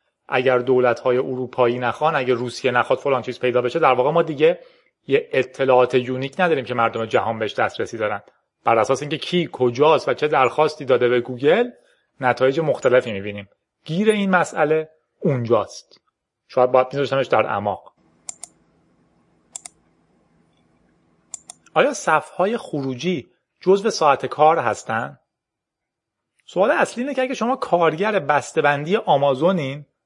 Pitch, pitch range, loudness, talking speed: 135 Hz, 125-175 Hz, -20 LUFS, 130 wpm